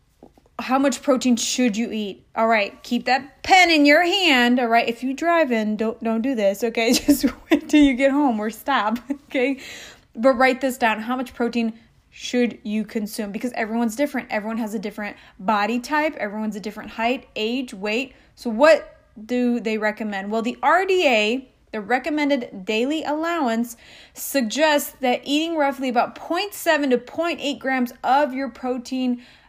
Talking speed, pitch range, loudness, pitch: 170 wpm, 225-280 Hz, -21 LUFS, 250 Hz